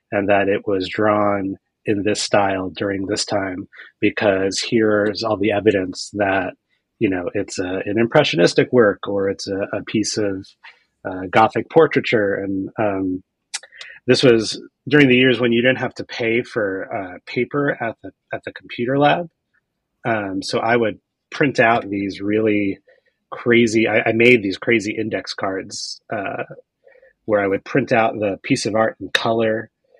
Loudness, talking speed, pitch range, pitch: -19 LUFS, 170 wpm, 100-120 Hz, 110 Hz